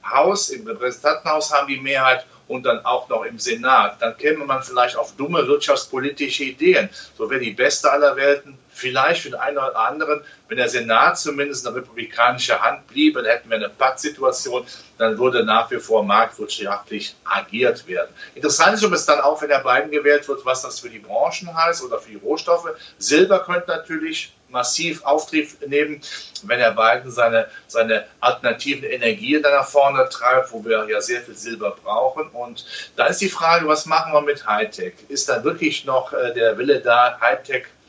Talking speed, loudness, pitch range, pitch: 185 wpm, -19 LUFS, 130-170 Hz, 150 Hz